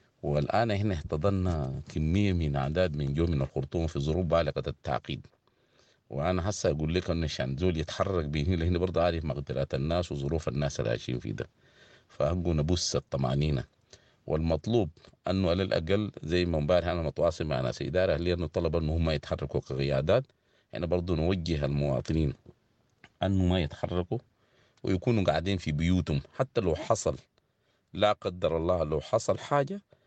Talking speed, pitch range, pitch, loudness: 150 wpm, 75-90 Hz, 85 Hz, -30 LUFS